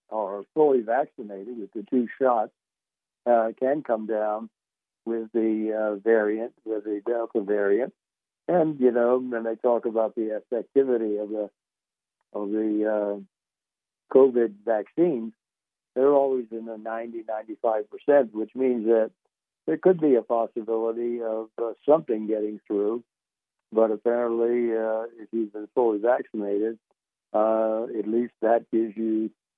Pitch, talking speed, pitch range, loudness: 115 Hz, 140 wpm, 110-120 Hz, -25 LUFS